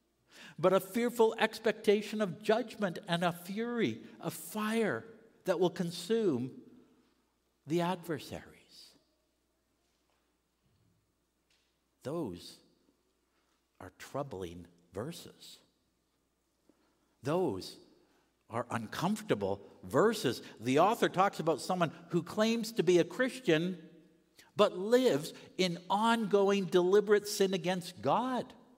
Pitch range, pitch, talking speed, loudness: 170-220 Hz, 190 Hz, 90 wpm, -32 LUFS